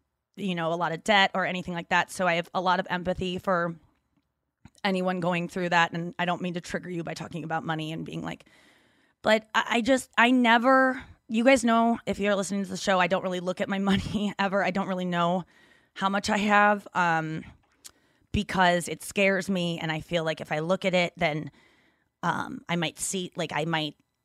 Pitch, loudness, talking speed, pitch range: 185 Hz, -26 LUFS, 220 wpm, 170-200 Hz